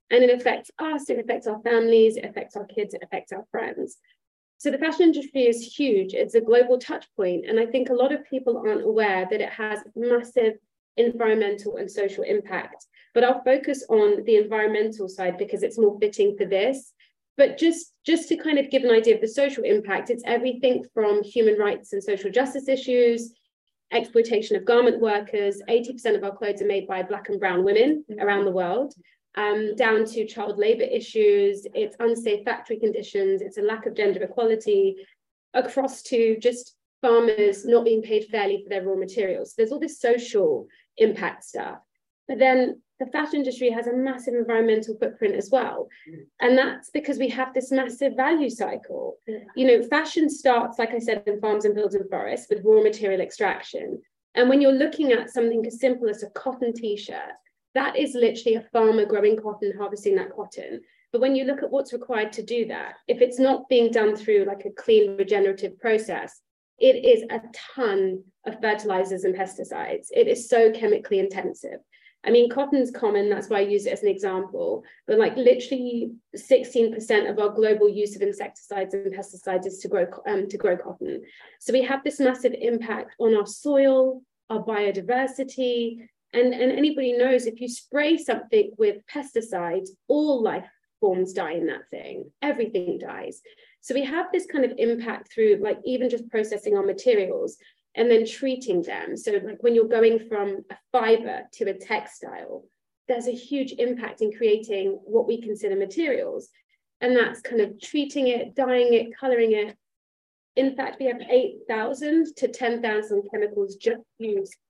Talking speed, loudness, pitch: 185 wpm, -23 LUFS, 255 Hz